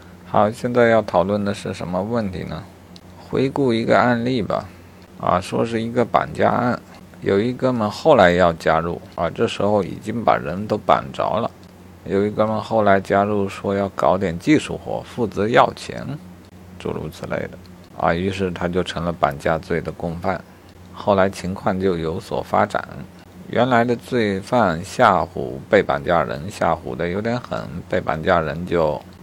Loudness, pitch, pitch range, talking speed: -20 LUFS, 95 Hz, 90-110 Hz, 240 characters per minute